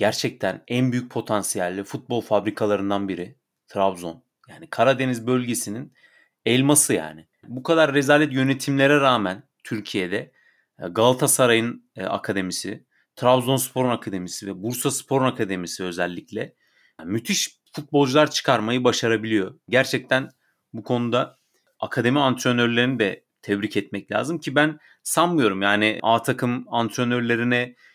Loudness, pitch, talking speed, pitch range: -22 LUFS, 120 Hz, 105 wpm, 105-130 Hz